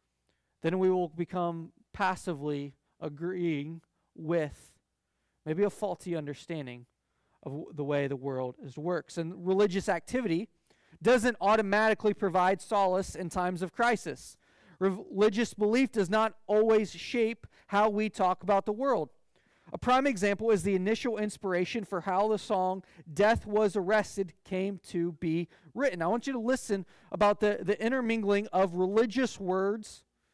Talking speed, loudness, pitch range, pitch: 145 wpm, -30 LUFS, 175-215 Hz, 195 Hz